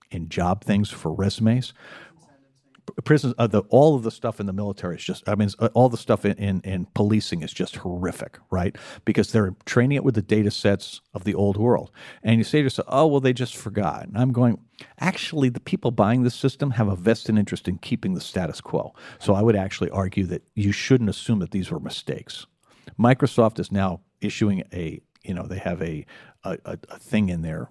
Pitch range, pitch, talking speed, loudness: 100-125 Hz, 110 Hz, 215 wpm, -23 LUFS